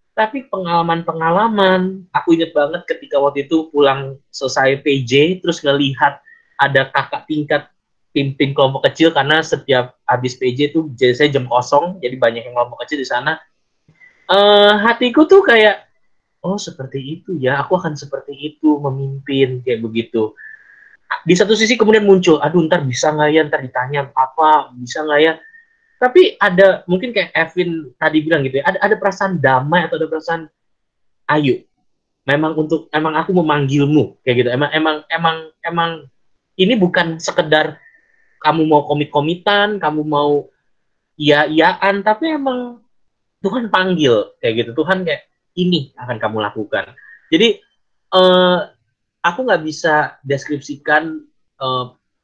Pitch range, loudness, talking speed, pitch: 140-185 Hz, -15 LUFS, 145 wpm, 155 Hz